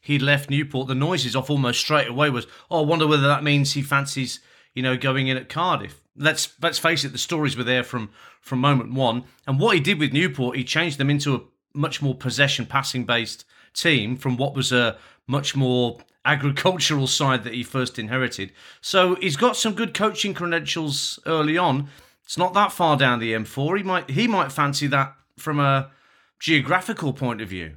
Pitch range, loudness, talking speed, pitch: 130-155 Hz, -22 LUFS, 200 wpm, 140 Hz